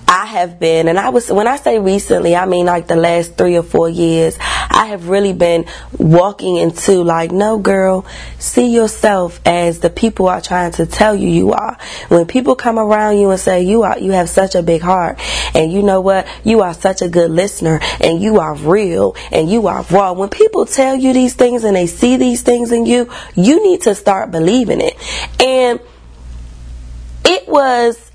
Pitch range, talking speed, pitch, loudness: 170-230 Hz, 205 wpm, 190 Hz, -12 LUFS